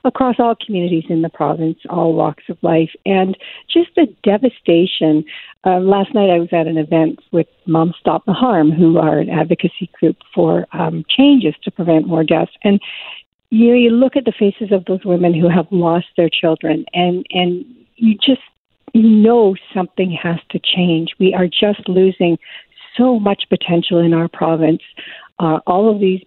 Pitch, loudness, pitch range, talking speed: 180 Hz, -15 LUFS, 165-205 Hz, 180 wpm